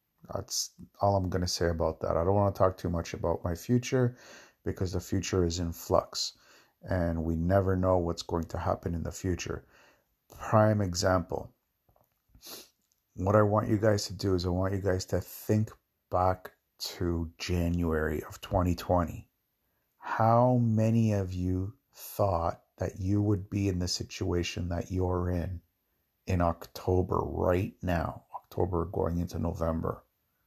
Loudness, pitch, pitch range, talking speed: -30 LUFS, 90 Hz, 85-100 Hz, 155 wpm